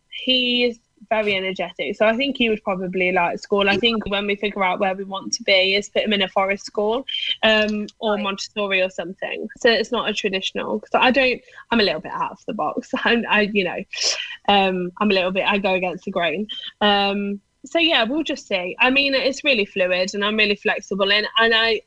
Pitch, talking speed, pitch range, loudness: 210 Hz, 230 wpm, 195-235 Hz, -20 LUFS